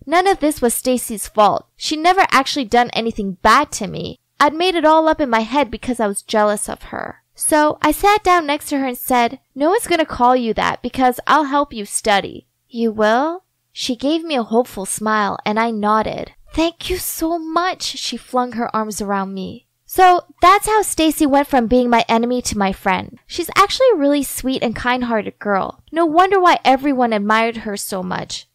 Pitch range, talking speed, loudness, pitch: 225-315 Hz, 205 wpm, -17 LUFS, 255 Hz